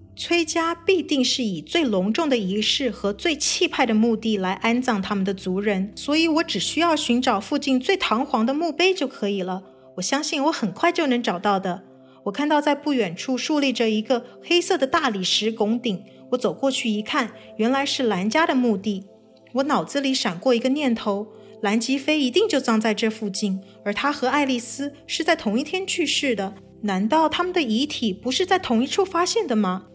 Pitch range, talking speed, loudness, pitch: 215-295 Hz, 290 characters per minute, -22 LUFS, 250 Hz